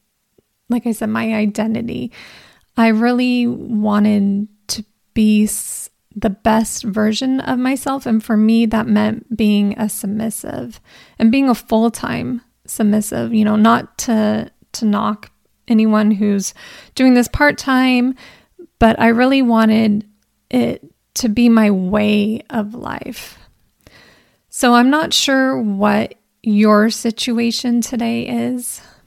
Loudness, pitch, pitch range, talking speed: -16 LUFS, 225 Hz, 215-245 Hz, 130 wpm